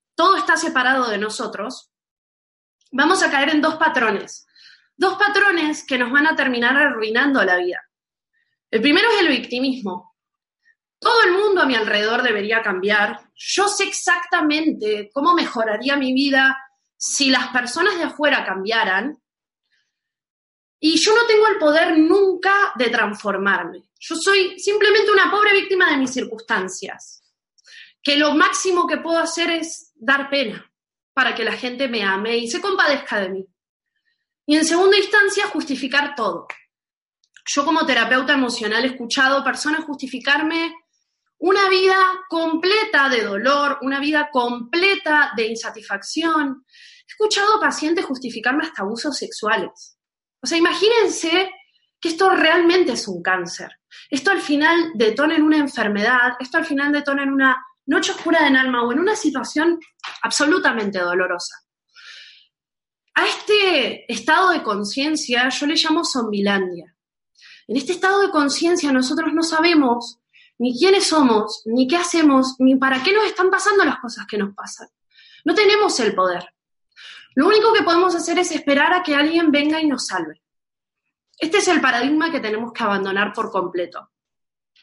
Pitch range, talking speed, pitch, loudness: 240-350 Hz, 150 wpm, 290 Hz, -18 LUFS